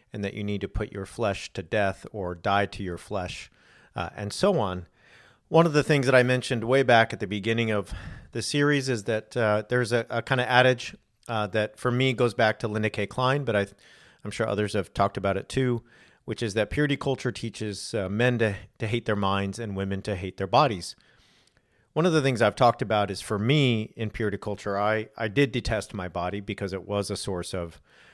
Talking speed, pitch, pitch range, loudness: 230 wpm, 110 Hz, 100-125 Hz, -26 LUFS